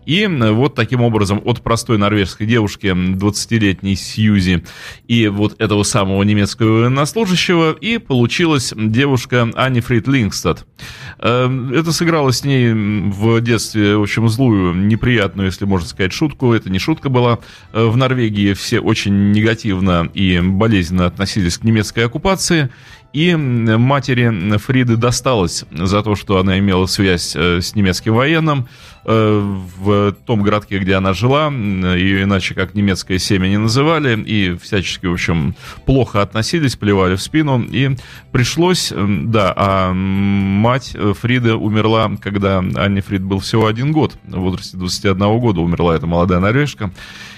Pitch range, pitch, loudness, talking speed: 100-125 Hz, 110 Hz, -15 LUFS, 135 wpm